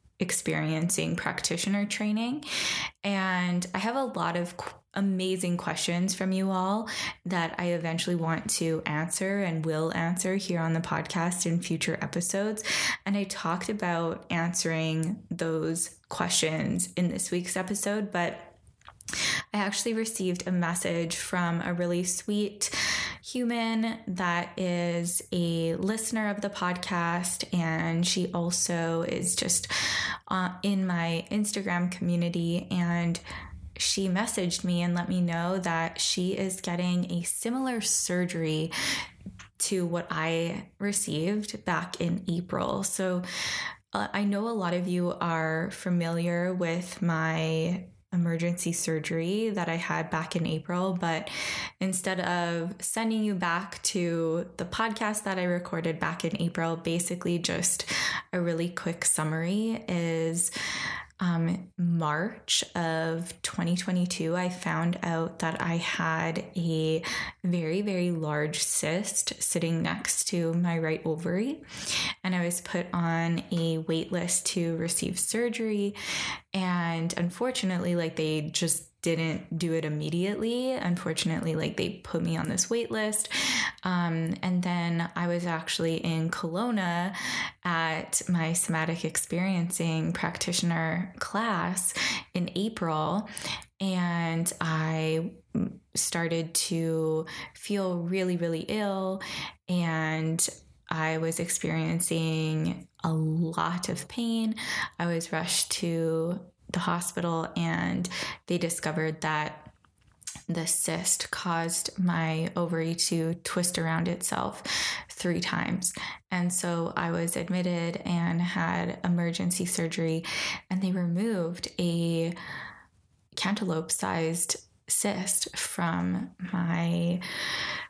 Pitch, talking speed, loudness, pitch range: 175 Hz, 120 wpm, -28 LUFS, 165-185 Hz